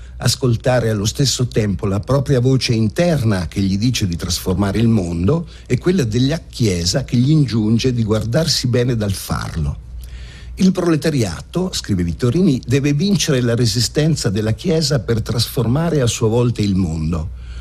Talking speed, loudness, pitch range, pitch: 150 wpm, -17 LUFS, 100-140 Hz, 120 Hz